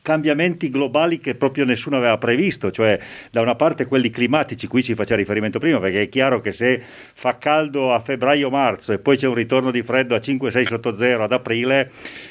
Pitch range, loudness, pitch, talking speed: 115-140 Hz, -19 LUFS, 130 Hz, 195 wpm